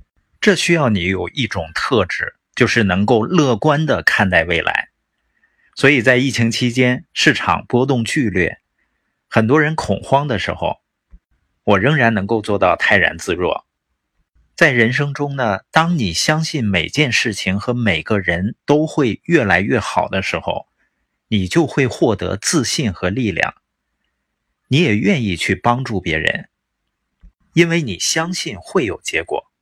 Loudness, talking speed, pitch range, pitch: -16 LUFS, 215 characters per minute, 100-150 Hz, 120 Hz